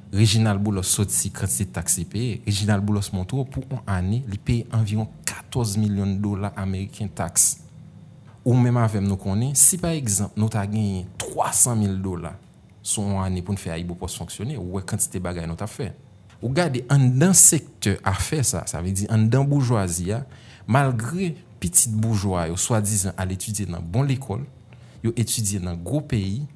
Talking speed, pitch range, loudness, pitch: 180 wpm, 95-120 Hz, -20 LUFS, 105 Hz